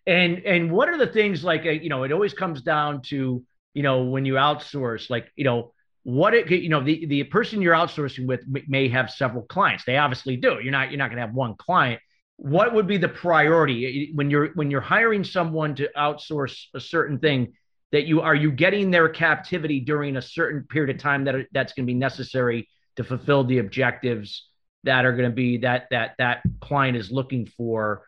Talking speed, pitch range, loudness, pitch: 205 wpm, 130-160 Hz, -22 LUFS, 140 Hz